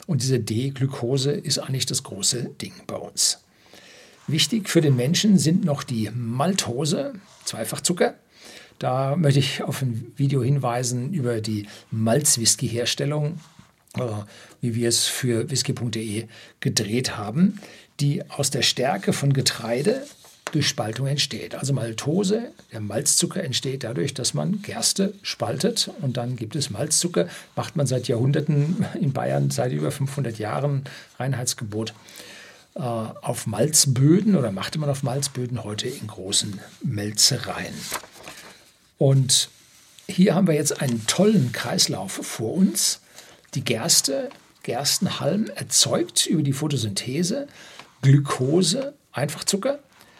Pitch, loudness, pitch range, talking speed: 135 Hz, -23 LUFS, 120-155 Hz, 120 wpm